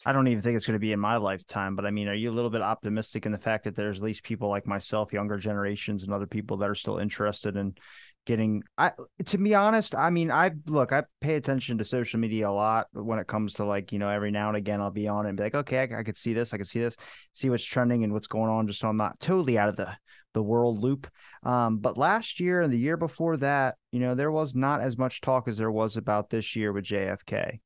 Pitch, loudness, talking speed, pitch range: 110 Hz, -28 LUFS, 280 wpm, 105-130 Hz